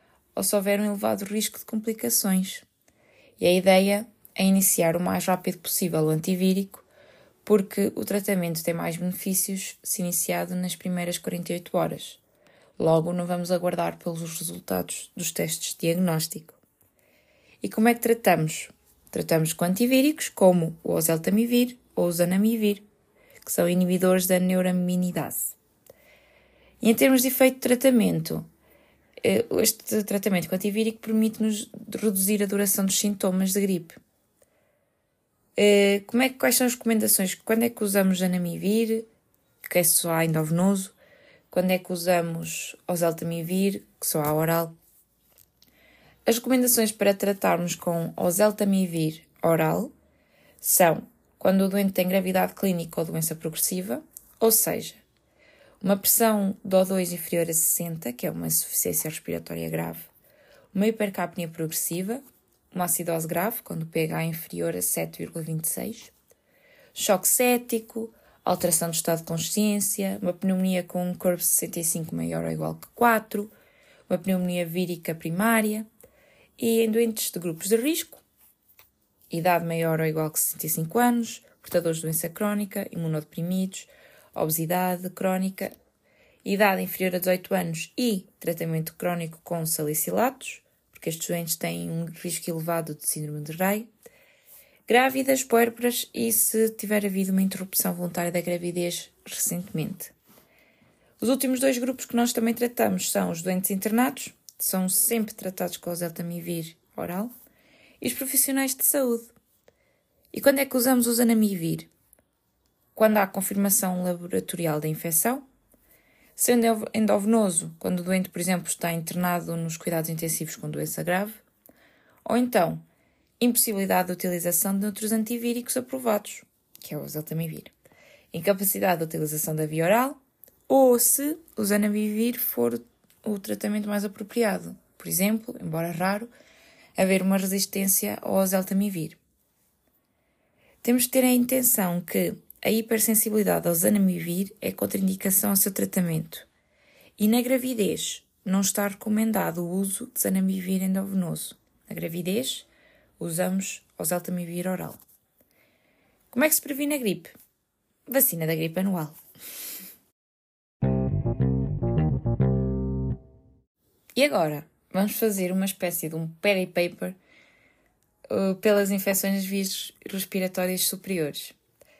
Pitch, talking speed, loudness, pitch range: 190 Hz, 130 wpm, -25 LUFS, 170-220 Hz